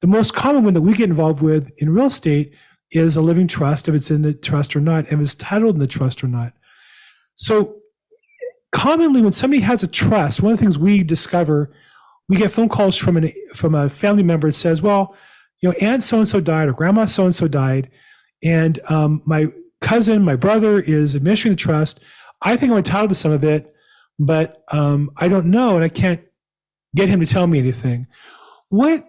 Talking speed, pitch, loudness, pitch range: 210 wpm, 170 Hz, -16 LUFS, 150-210 Hz